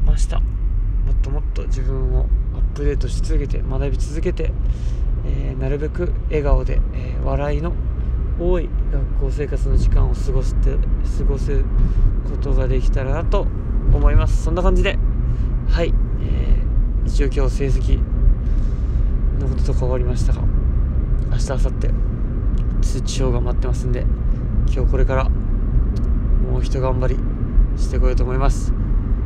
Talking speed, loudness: 290 characters per minute, -21 LUFS